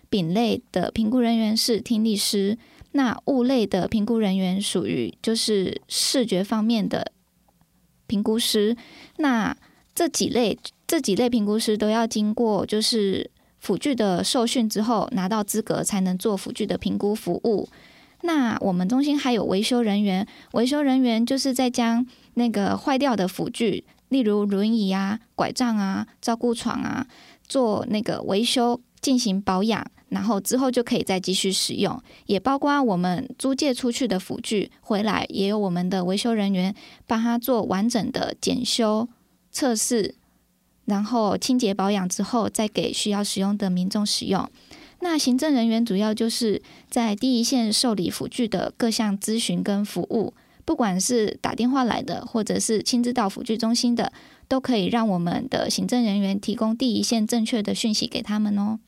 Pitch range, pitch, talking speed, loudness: 205-245 Hz, 225 Hz, 255 characters per minute, -23 LUFS